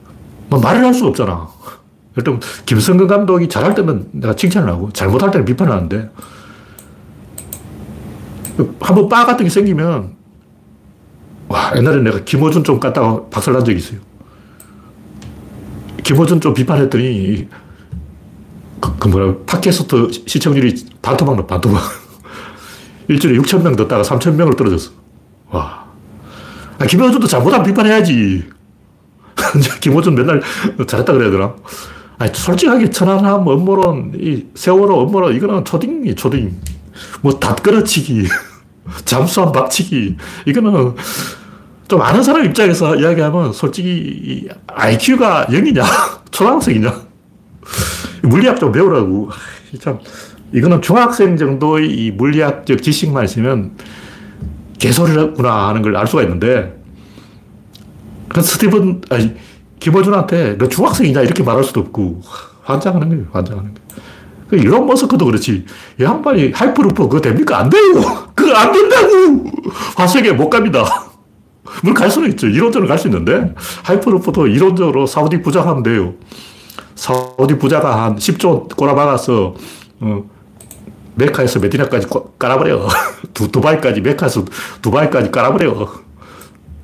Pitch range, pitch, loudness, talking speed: 105-175 Hz, 135 Hz, -13 LUFS, 290 characters per minute